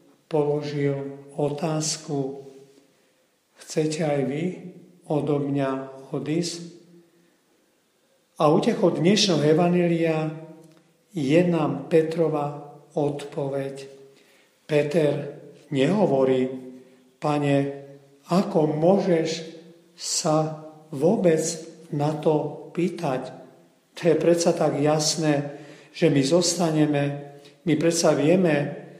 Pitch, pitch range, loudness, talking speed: 155 Hz, 145-165 Hz, -23 LUFS, 75 wpm